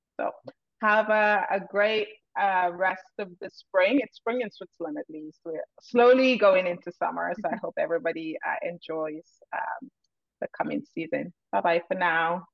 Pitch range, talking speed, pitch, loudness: 170-215 Hz, 170 wpm, 190 Hz, -26 LUFS